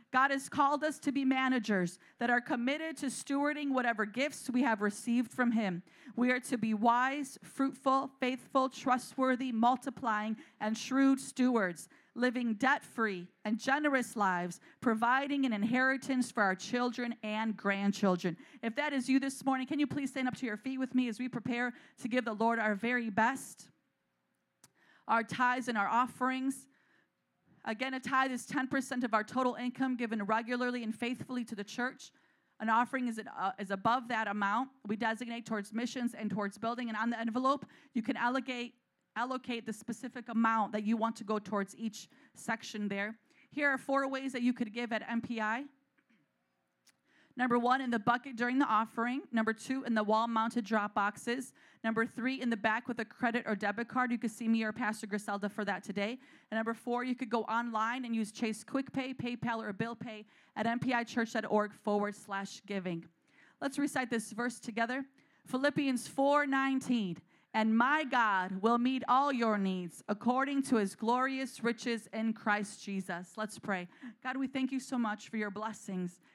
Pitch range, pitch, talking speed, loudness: 220-260 Hz, 240 Hz, 180 wpm, -34 LUFS